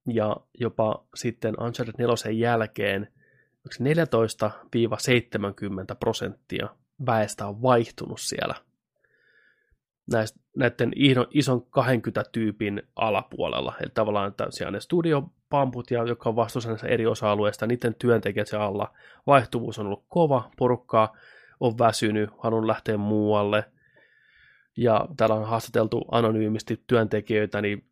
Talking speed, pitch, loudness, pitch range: 105 wpm, 115 Hz, -25 LUFS, 105-125 Hz